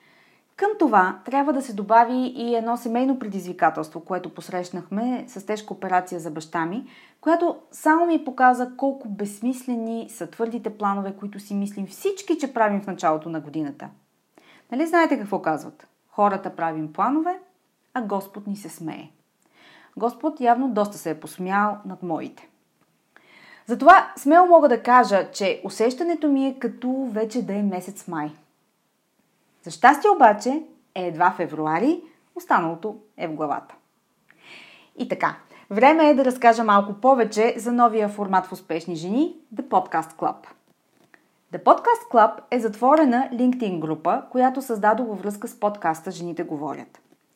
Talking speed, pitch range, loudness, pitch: 145 wpm, 185-265 Hz, -22 LUFS, 220 Hz